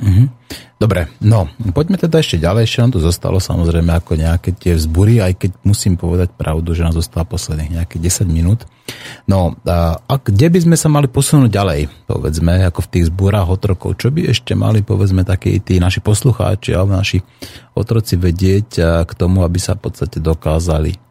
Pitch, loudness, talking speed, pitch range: 95 Hz, -14 LUFS, 175 wpm, 85-115 Hz